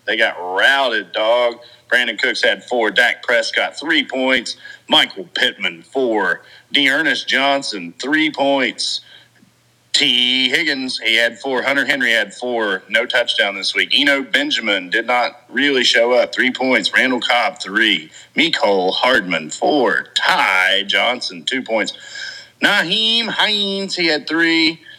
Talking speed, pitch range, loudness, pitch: 135 wpm, 120-155 Hz, -16 LUFS, 130 Hz